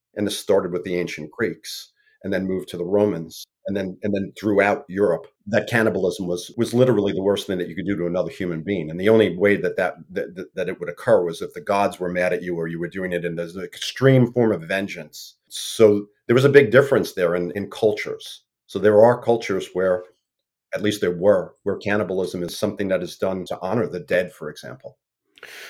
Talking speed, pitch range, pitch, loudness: 225 wpm, 90-105 Hz, 95 Hz, -21 LUFS